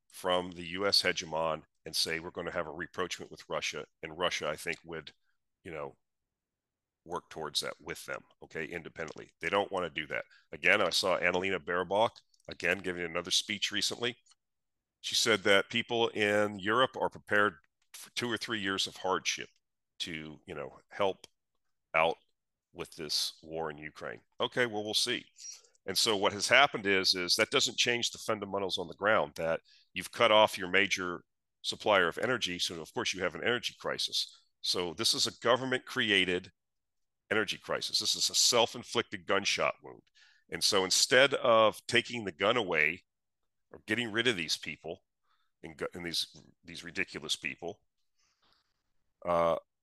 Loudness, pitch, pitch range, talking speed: -30 LUFS, 95 Hz, 90-110 Hz, 170 wpm